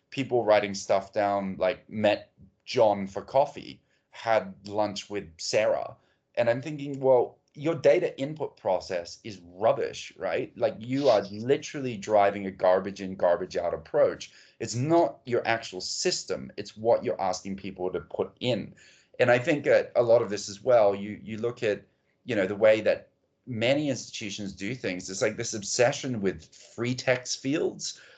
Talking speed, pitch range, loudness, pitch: 170 wpm, 100-130 Hz, -27 LUFS, 110 Hz